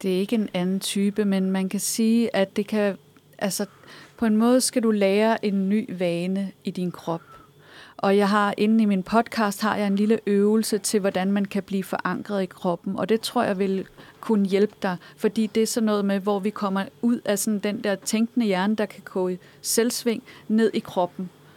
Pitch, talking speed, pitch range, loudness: 205 Hz, 215 wpm, 190-220 Hz, -24 LUFS